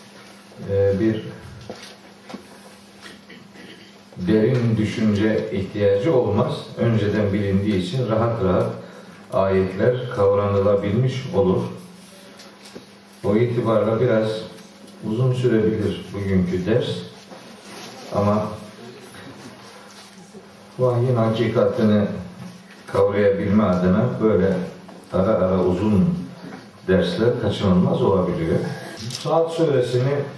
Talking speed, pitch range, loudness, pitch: 65 wpm, 100-120 Hz, -20 LUFS, 110 Hz